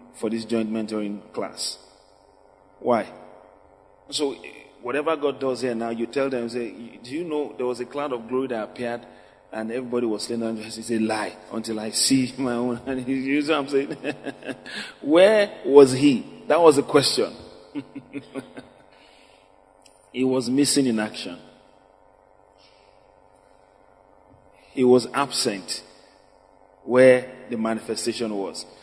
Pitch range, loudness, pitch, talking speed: 115-135 Hz, -23 LUFS, 125 Hz, 135 wpm